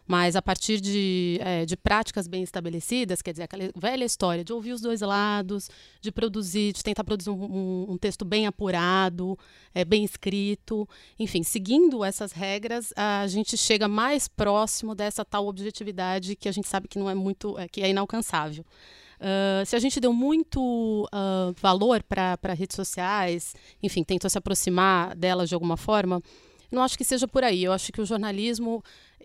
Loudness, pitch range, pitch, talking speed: -26 LUFS, 185-215 Hz, 200 Hz, 170 wpm